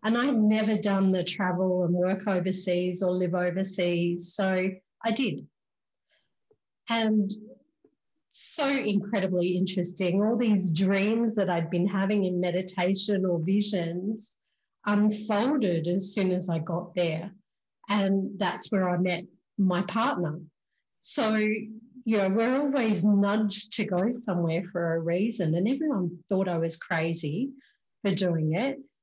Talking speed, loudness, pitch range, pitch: 135 wpm, -27 LUFS, 180-215 Hz, 195 Hz